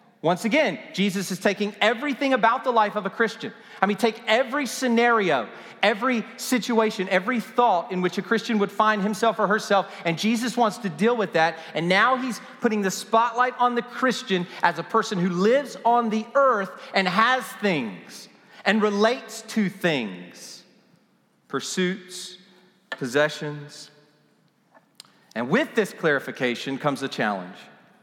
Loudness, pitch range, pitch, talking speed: -23 LUFS, 180-235 Hz, 210 Hz, 150 wpm